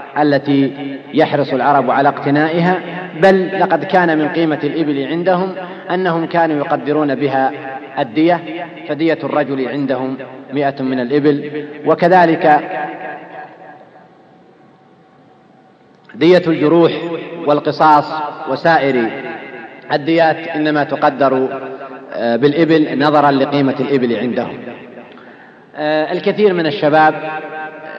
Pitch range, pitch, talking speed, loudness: 140-165 Hz, 150 Hz, 85 wpm, -14 LUFS